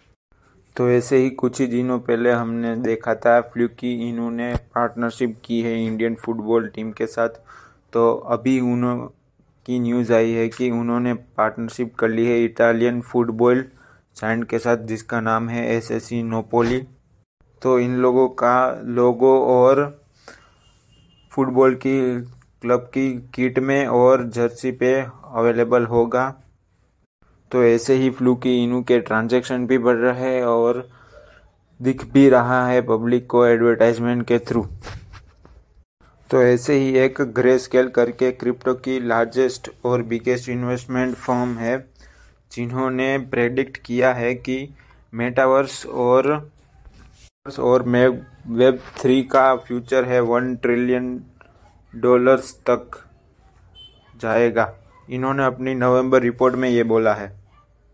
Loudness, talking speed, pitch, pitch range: -19 LUFS, 130 wpm, 125 Hz, 115-130 Hz